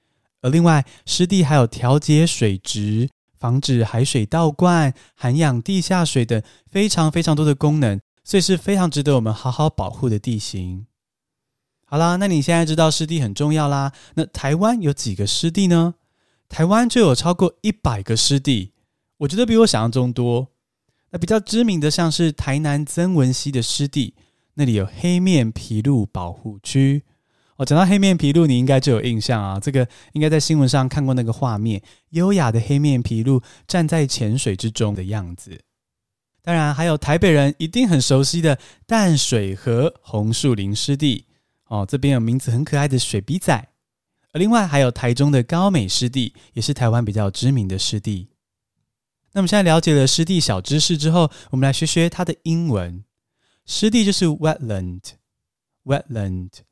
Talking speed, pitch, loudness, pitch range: 285 characters per minute, 140 Hz, -19 LUFS, 115-165 Hz